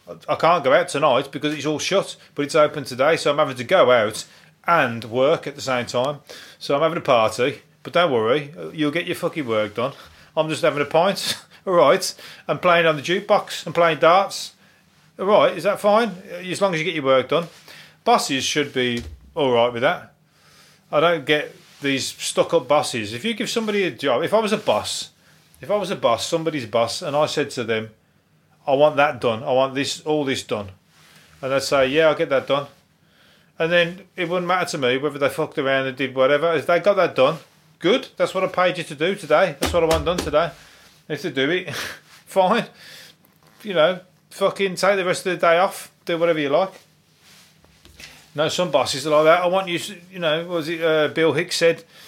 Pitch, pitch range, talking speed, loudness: 160 Hz, 140-180 Hz, 225 wpm, -20 LUFS